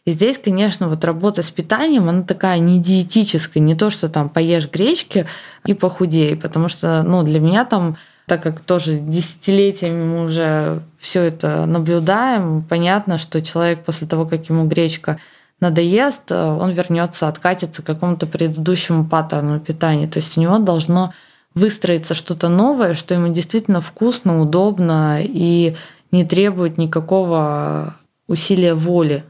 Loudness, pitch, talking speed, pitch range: -17 LUFS, 170 Hz, 145 wpm, 160-185 Hz